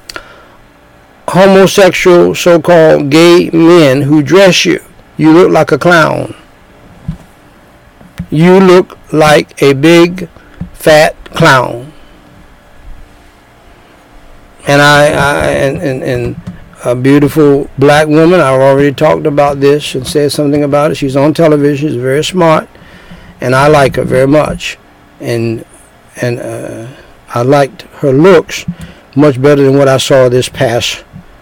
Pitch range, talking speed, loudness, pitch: 135-160 Hz, 125 wpm, -7 LUFS, 145 Hz